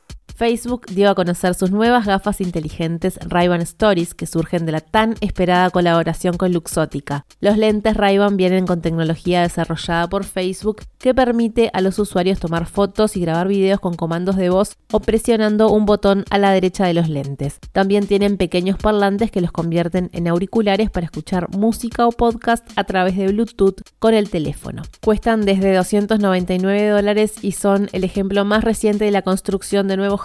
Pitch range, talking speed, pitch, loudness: 180-210 Hz, 175 wpm, 195 Hz, -18 LUFS